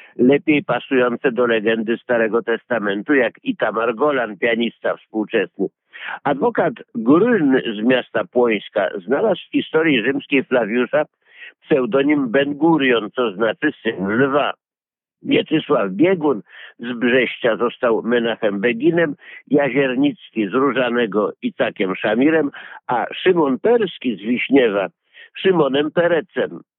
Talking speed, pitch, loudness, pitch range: 105 wpm, 130 Hz, -18 LUFS, 115-150 Hz